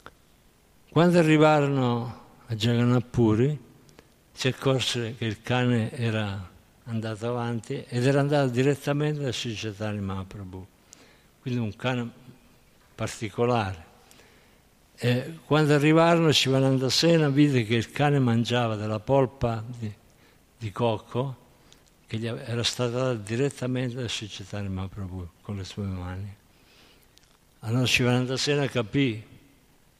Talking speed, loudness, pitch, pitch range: 110 wpm, -25 LUFS, 120 Hz, 110-135 Hz